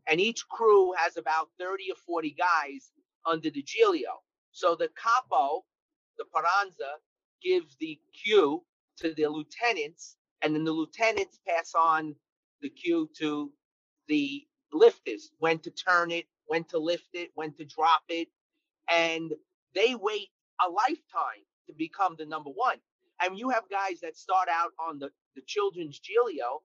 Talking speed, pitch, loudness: 155 wpm, 200 Hz, -29 LUFS